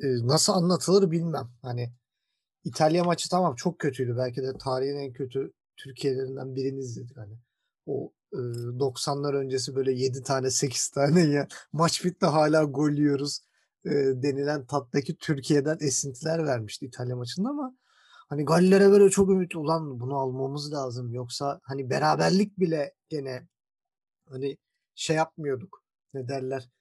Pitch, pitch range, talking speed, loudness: 140 Hz, 130-160 Hz, 135 wpm, -26 LUFS